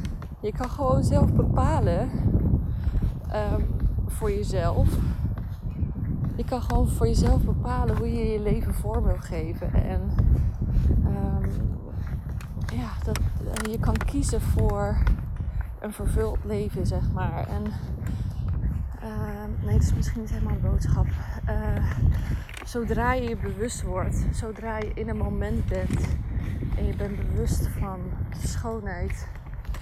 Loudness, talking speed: -27 LUFS, 125 wpm